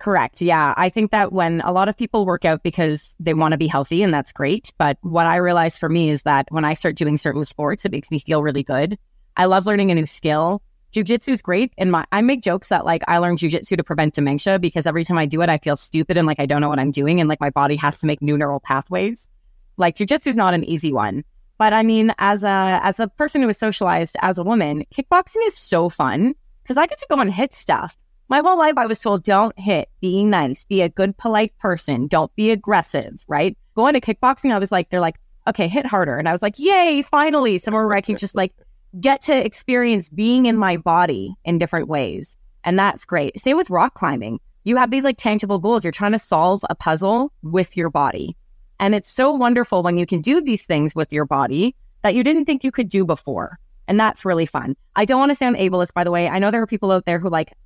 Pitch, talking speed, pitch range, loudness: 185 Hz, 250 wpm, 160-220 Hz, -19 LUFS